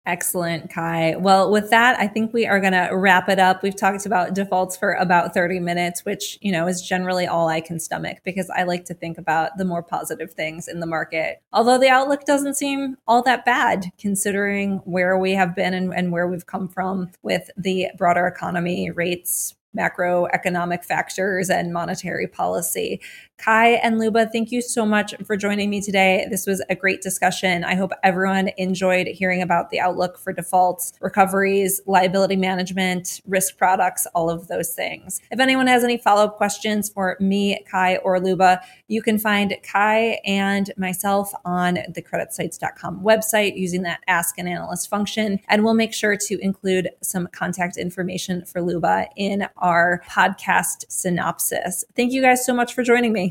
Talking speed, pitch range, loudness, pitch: 180 wpm, 180-205 Hz, -20 LUFS, 190 Hz